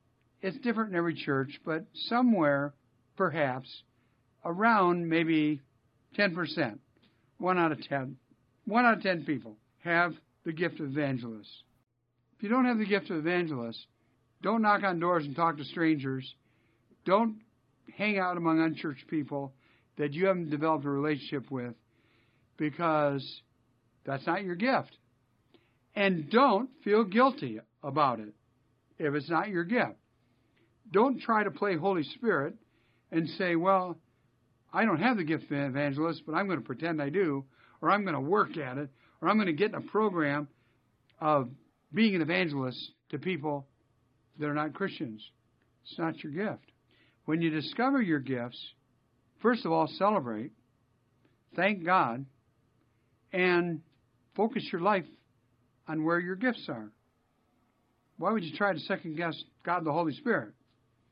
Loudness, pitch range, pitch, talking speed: -30 LUFS, 125-180 Hz, 150 Hz, 155 wpm